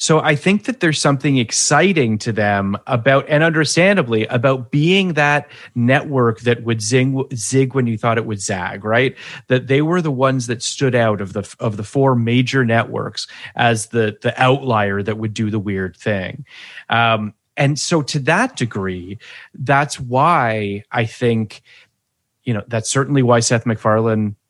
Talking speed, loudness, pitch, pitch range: 170 wpm, -17 LUFS, 120 Hz, 110-140 Hz